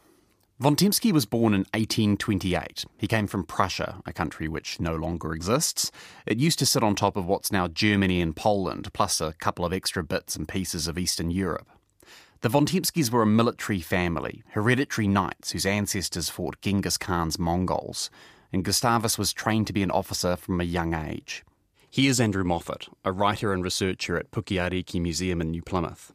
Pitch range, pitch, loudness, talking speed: 90-110 Hz, 100 Hz, -26 LUFS, 175 wpm